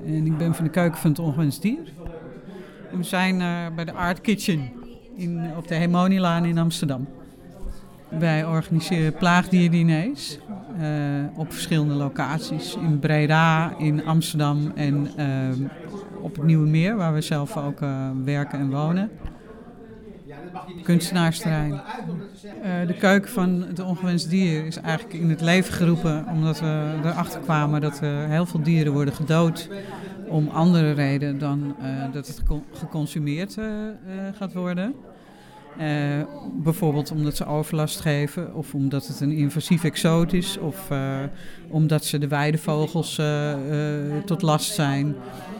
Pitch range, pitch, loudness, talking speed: 150-180 Hz, 160 Hz, -23 LUFS, 130 wpm